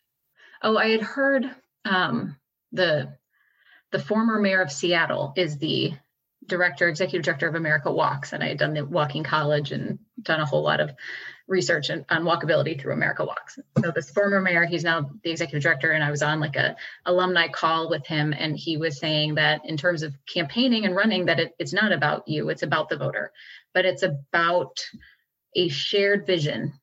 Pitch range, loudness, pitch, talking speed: 155-185 Hz, -24 LUFS, 170 Hz, 190 wpm